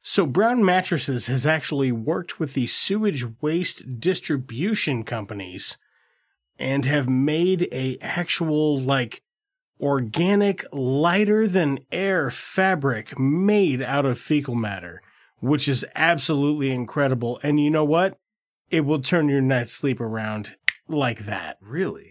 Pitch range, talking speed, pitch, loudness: 130-175 Hz, 125 wpm, 145 Hz, -23 LUFS